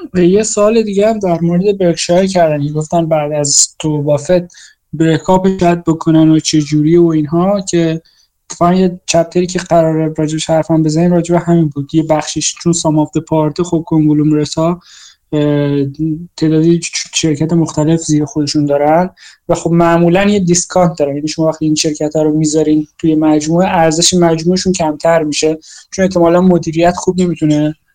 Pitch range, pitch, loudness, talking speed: 155-175 Hz, 165 Hz, -12 LUFS, 160 wpm